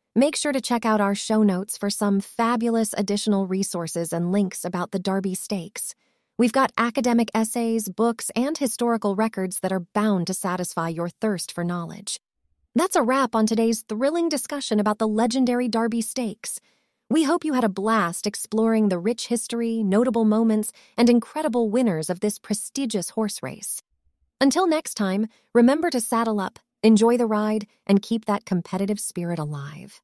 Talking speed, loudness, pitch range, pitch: 170 wpm, -23 LUFS, 195-240 Hz, 220 Hz